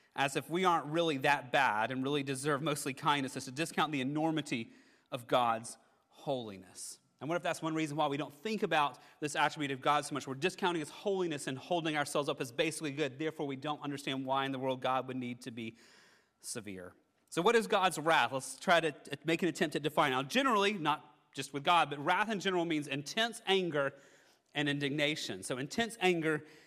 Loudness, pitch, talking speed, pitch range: -34 LUFS, 150 Hz, 210 wpm, 140-165 Hz